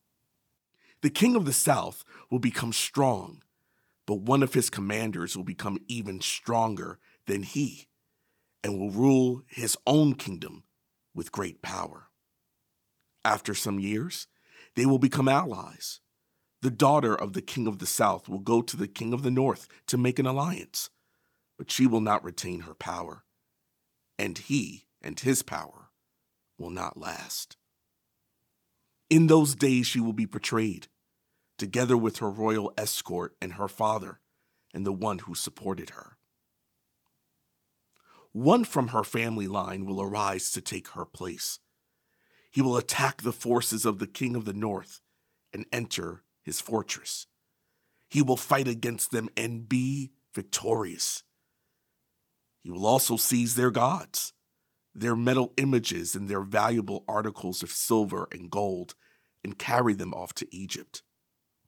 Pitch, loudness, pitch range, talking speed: 115 Hz, -28 LUFS, 100-130 Hz, 145 wpm